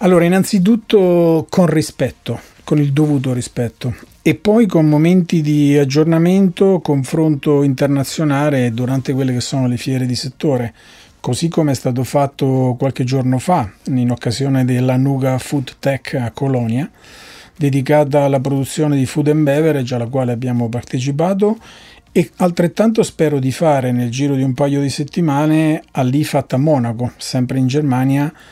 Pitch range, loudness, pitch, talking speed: 130-155 Hz, -15 LUFS, 140 Hz, 145 wpm